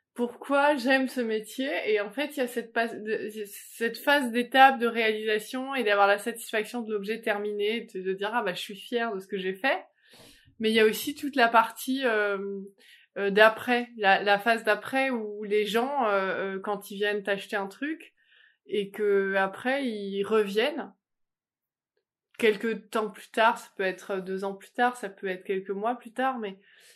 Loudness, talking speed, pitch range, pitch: -27 LUFS, 185 wpm, 205-245 Hz, 220 Hz